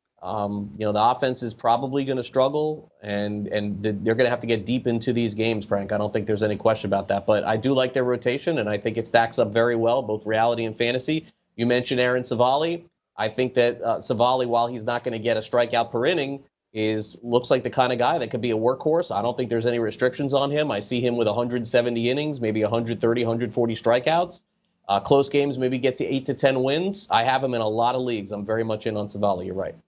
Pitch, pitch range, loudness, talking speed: 120 Hz, 110-130 Hz, -23 LUFS, 250 wpm